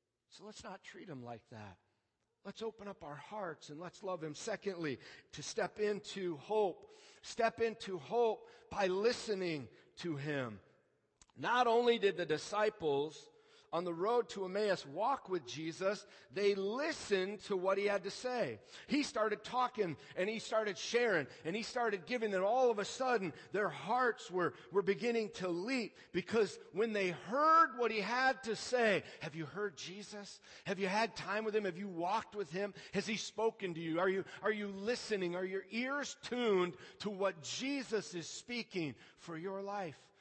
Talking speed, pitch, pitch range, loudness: 175 wpm, 200 Hz, 180-230 Hz, -37 LUFS